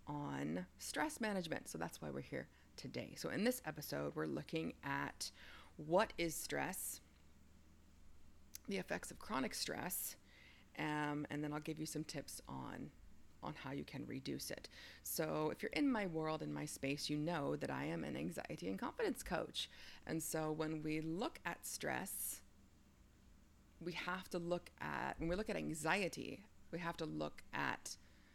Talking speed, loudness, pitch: 170 wpm, -44 LUFS, 140 Hz